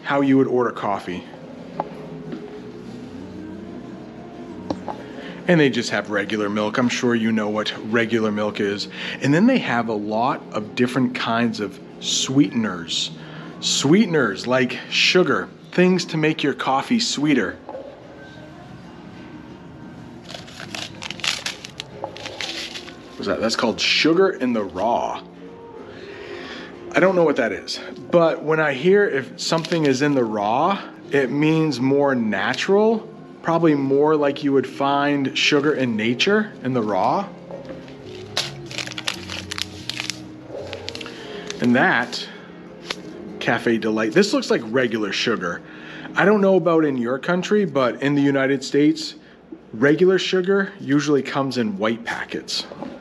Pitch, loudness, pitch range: 135 Hz, -20 LUFS, 115-165 Hz